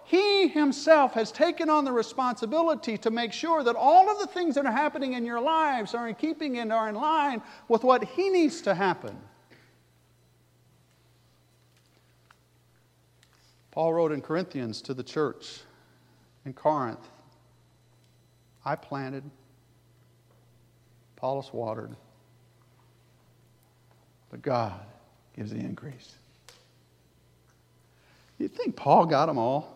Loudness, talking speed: -26 LUFS, 115 wpm